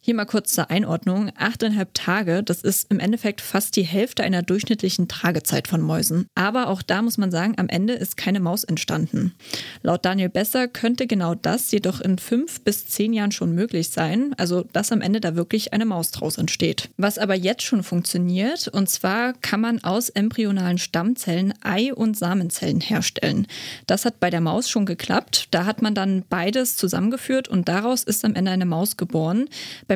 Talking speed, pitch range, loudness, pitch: 190 wpm, 180-225 Hz, -22 LUFS, 200 Hz